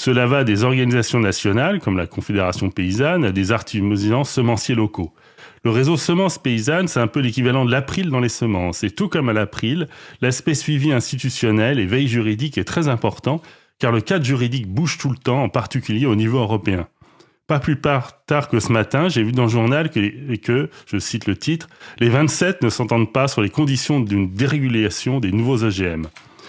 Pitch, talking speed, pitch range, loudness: 125 Hz, 195 wpm, 110-140 Hz, -19 LUFS